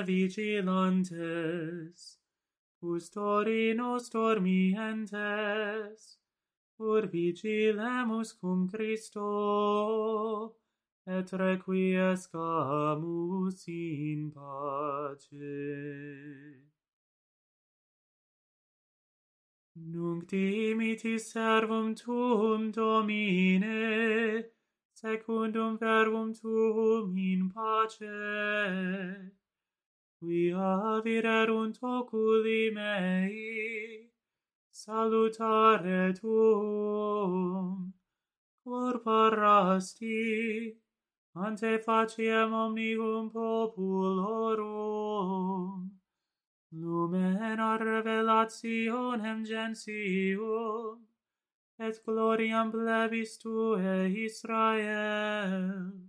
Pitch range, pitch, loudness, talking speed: 185-225 Hz, 215 Hz, -31 LUFS, 45 wpm